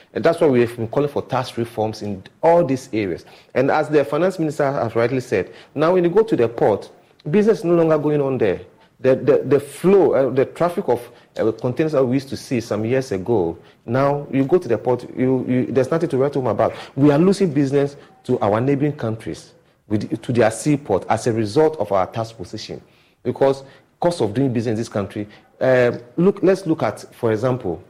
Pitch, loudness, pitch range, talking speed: 130 Hz, -19 LUFS, 115-150 Hz, 220 wpm